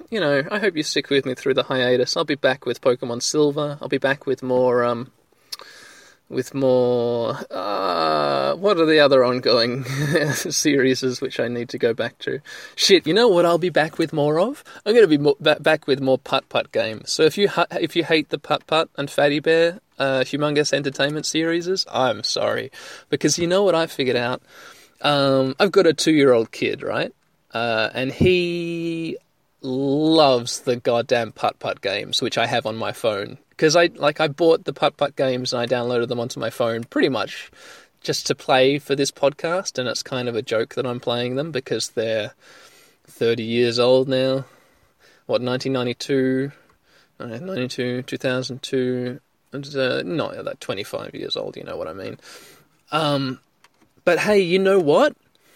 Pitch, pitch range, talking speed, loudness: 140 Hz, 125-160 Hz, 185 wpm, -20 LUFS